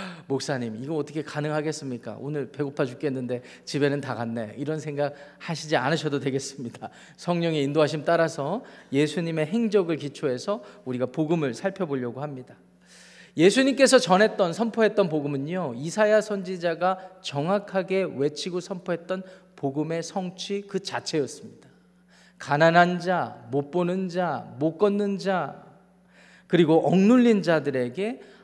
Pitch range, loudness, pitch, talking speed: 145-190 Hz, -25 LUFS, 165 Hz, 315 characters per minute